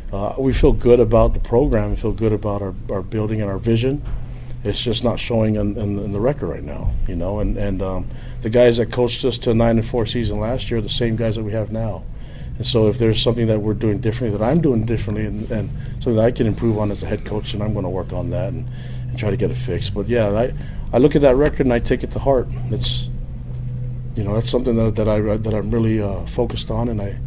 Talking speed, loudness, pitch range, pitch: 270 wpm, -20 LUFS, 105-125 Hz, 115 Hz